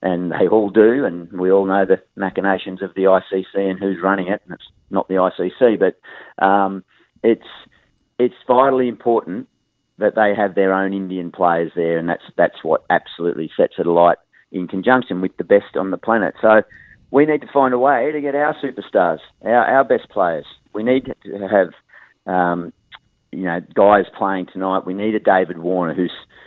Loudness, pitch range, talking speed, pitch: -18 LUFS, 90-110 Hz, 190 wpm, 95 Hz